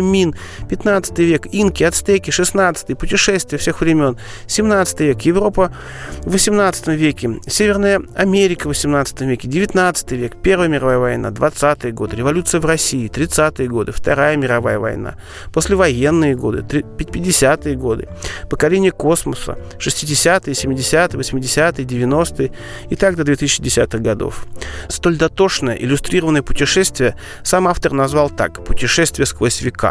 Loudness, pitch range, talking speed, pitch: -16 LUFS, 130-180 Hz, 120 wpm, 150 Hz